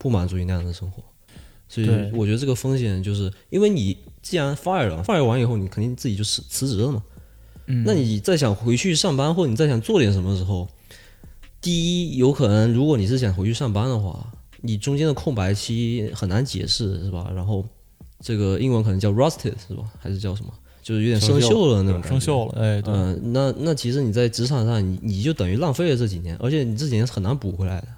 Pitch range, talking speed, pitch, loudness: 95-130 Hz, 355 characters per minute, 110 Hz, -22 LUFS